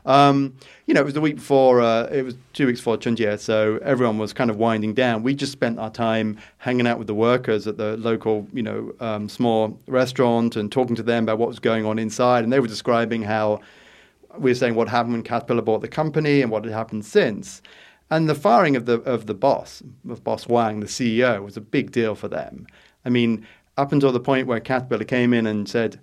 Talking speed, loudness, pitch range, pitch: 235 wpm, -21 LUFS, 110-130 Hz, 115 Hz